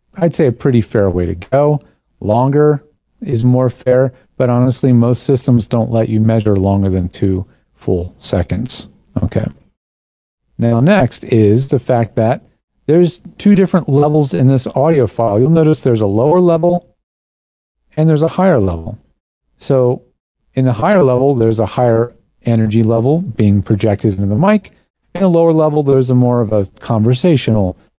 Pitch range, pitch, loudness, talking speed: 110-150 Hz, 125 Hz, -13 LUFS, 165 wpm